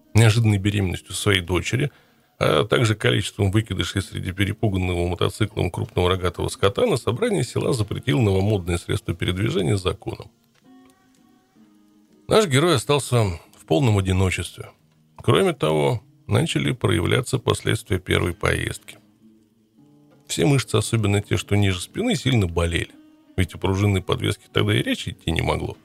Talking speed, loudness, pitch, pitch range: 125 wpm, -22 LUFS, 105 Hz, 95-115 Hz